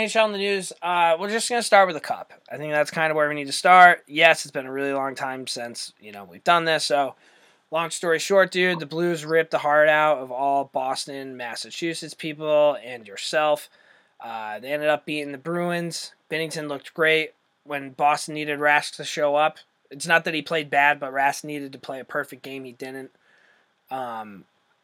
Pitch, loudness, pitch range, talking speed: 150 Hz, -22 LUFS, 140-165 Hz, 215 wpm